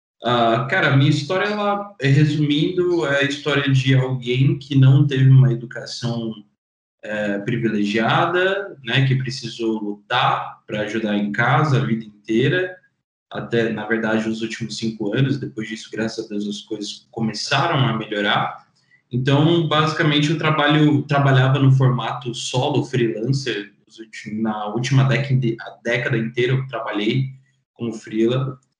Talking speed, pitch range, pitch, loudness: 135 wpm, 110-140 Hz, 125 Hz, -20 LUFS